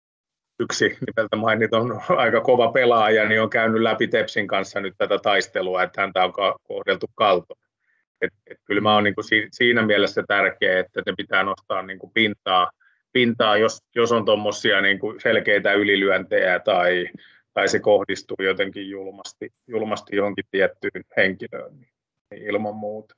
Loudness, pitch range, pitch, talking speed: -21 LUFS, 100-110 Hz, 105 Hz, 145 wpm